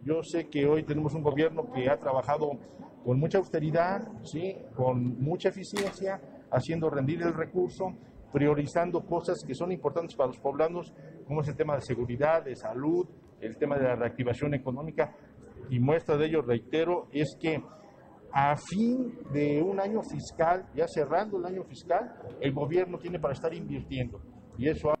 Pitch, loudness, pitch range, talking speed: 155 Hz, -30 LUFS, 140-170 Hz, 170 wpm